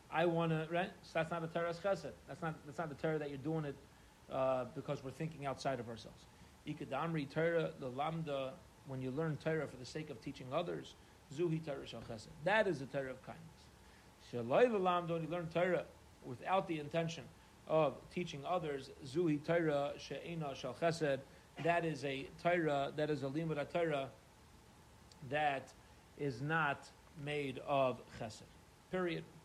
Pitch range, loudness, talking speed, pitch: 135-165 Hz, -39 LUFS, 165 wpm, 150 Hz